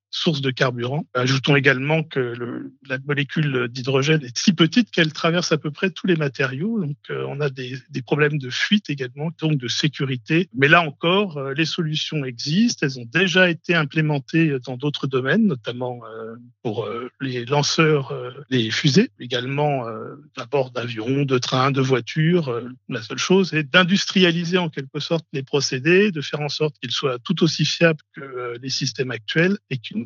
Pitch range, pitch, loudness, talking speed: 130-165 Hz, 145 Hz, -21 LUFS, 185 wpm